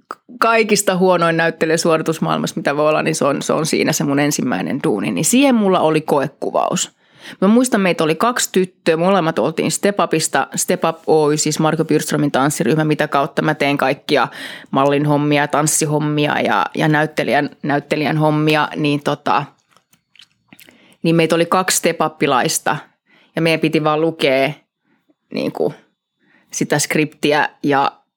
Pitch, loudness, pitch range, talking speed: 160 Hz, -16 LUFS, 150-180 Hz, 145 wpm